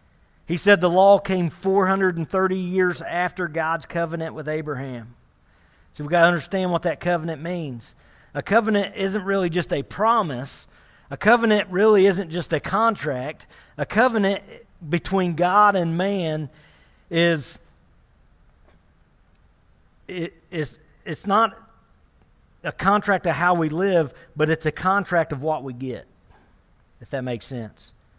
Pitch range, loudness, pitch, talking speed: 150-195 Hz, -22 LUFS, 170 Hz, 135 wpm